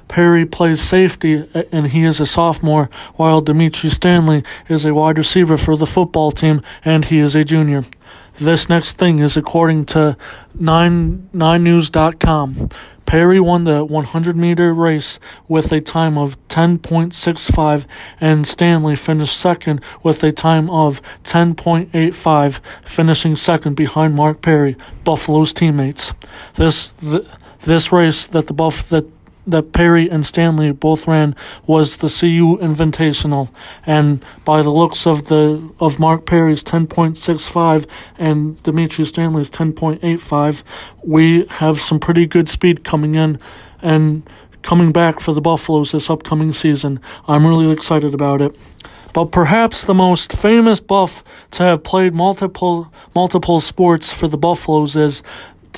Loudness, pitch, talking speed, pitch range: -14 LUFS, 160 Hz, 140 wpm, 155-170 Hz